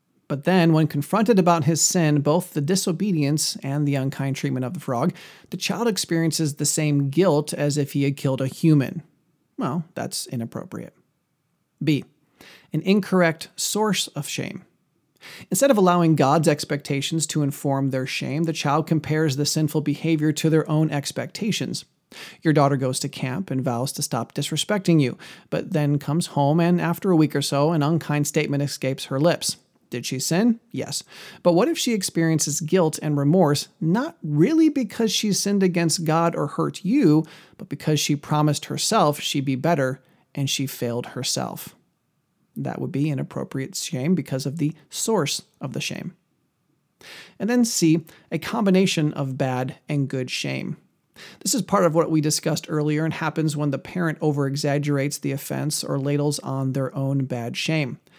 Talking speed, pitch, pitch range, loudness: 170 wpm, 155 Hz, 140-170 Hz, -22 LUFS